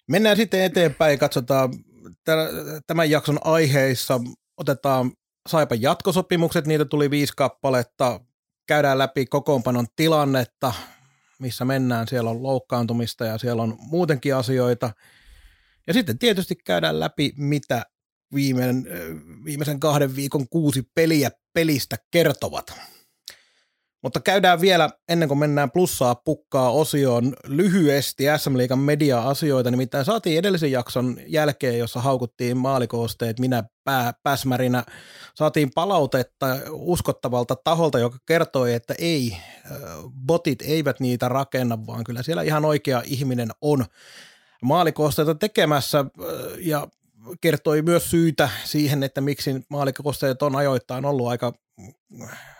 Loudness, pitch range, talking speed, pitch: -22 LUFS, 125-155 Hz, 110 wpm, 140 Hz